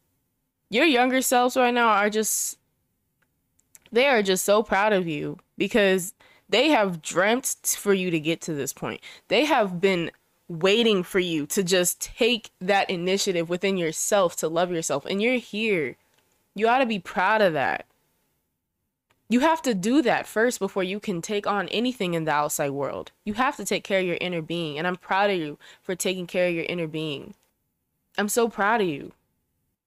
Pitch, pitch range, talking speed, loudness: 195 Hz, 175-220 Hz, 185 wpm, -24 LUFS